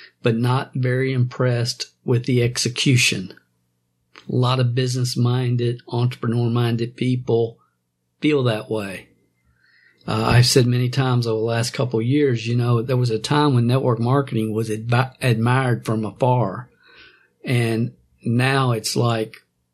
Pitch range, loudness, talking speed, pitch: 115-125 Hz, -20 LUFS, 140 wpm, 120 Hz